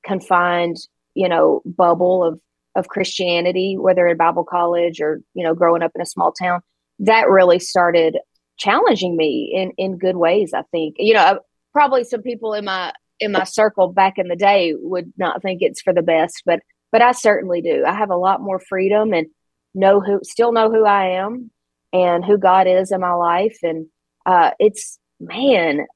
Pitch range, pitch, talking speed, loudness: 175-200 Hz, 185 Hz, 190 wpm, -17 LUFS